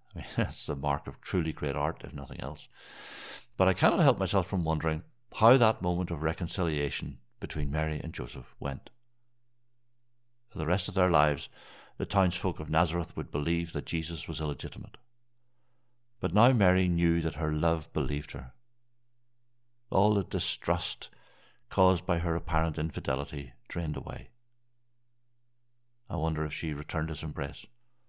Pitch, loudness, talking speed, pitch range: 90 Hz, -30 LUFS, 150 wpm, 80-120 Hz